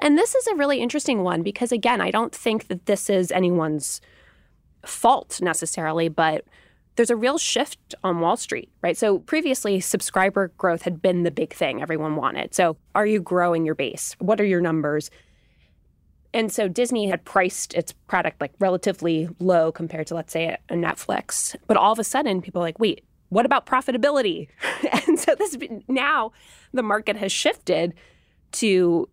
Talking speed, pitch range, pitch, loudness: 175 wpm, 170-235 Hz, 195 Hz, -23 LUFS